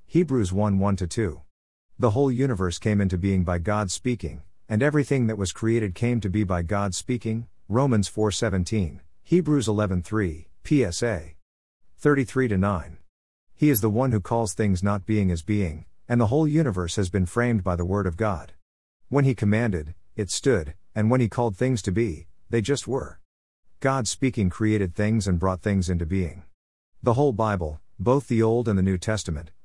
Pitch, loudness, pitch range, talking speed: 105 Hz, -24 LUFS, 90-120 Hz, 185 wpm